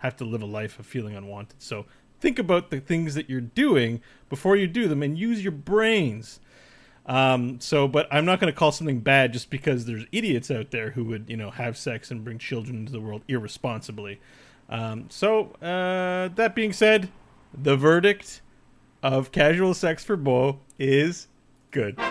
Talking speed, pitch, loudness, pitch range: 185 wpm, 135 Hz, -24 LUFS, 120-170 Hz